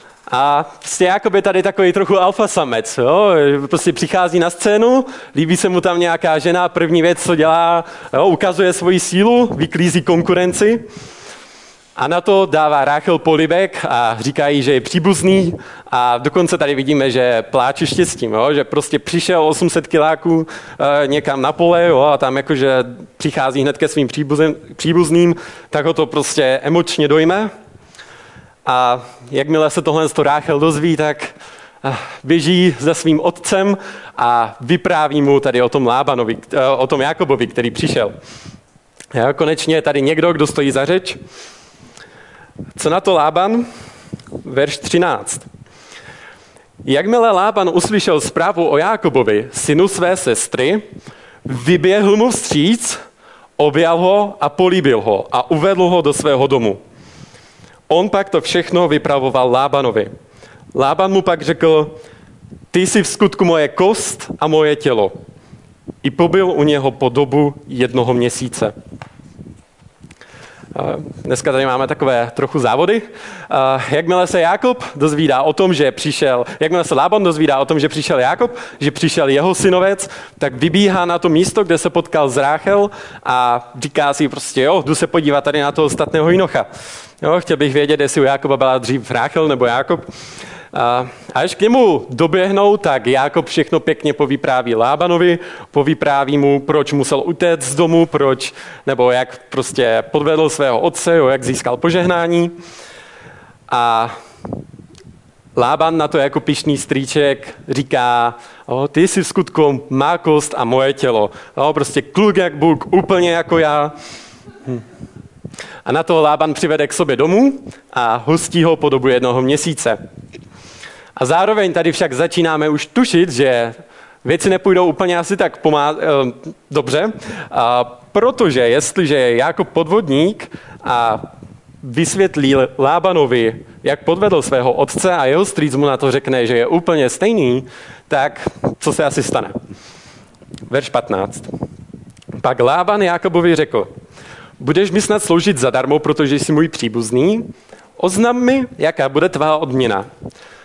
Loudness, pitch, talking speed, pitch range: -14 LUFS, 155 Hz, 145 wpm, 140-180 Hz